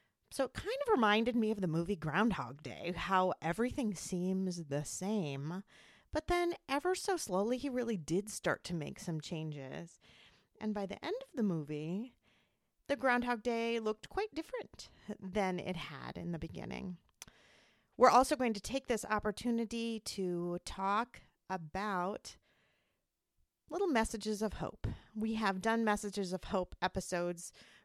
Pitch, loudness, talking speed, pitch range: 205 Hz, -36 LUFS, 150 wpm, 180-240 Hz